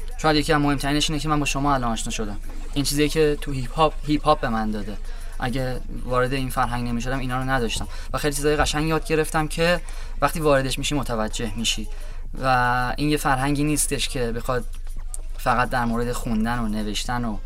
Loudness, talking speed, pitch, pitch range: -23 LUFS, 195 wpm, 125 Hz, 110-145 Hz